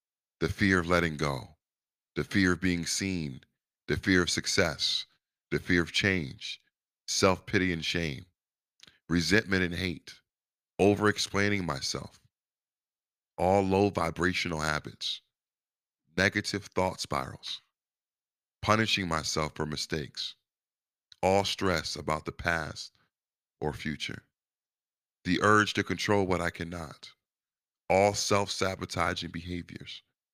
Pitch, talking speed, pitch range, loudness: 90 Hz, 115 wpm, 85-100 Hz, -29 LUFS